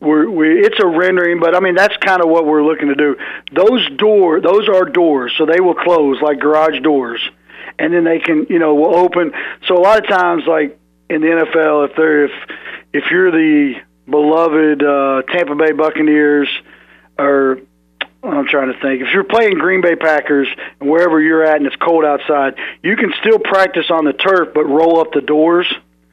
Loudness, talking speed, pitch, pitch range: -13 LUFS, 200 wpm, 160 Hz, 145-180 Hz